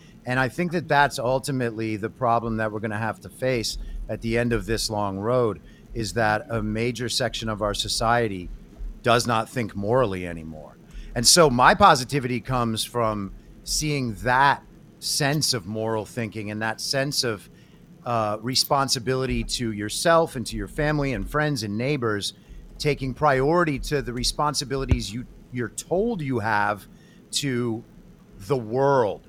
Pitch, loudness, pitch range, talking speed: 120 Hz, -24 LUFS, 110-135 Hz, 155 wpm